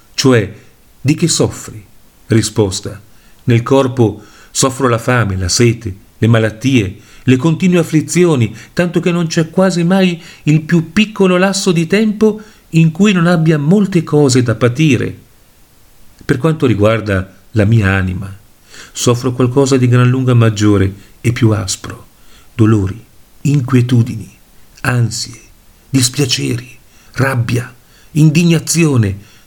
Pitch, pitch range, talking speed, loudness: 125 Hz, 110-155 Hz, 120 wpm, -13 LUFS